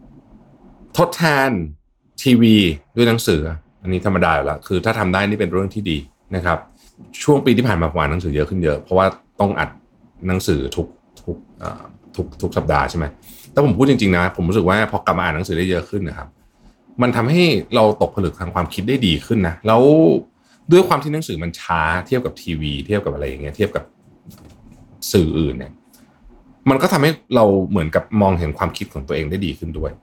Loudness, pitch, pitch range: -18 LUFS, 95 Hz, 80-110 Hz